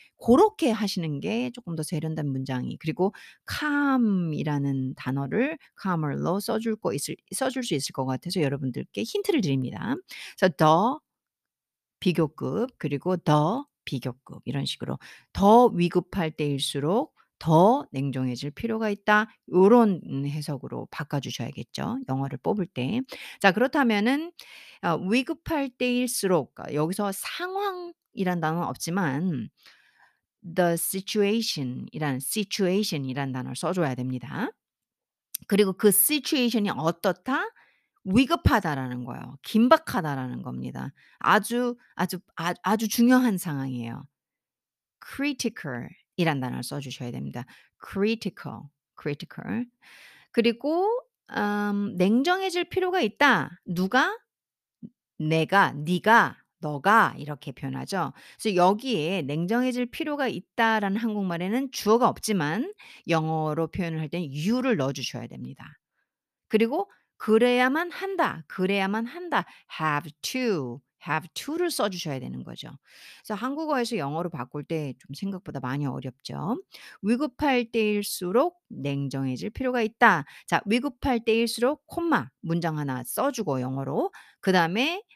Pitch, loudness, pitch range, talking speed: 190 Hz, -26 LUFS, 150-240 Hz, 305 characters per minute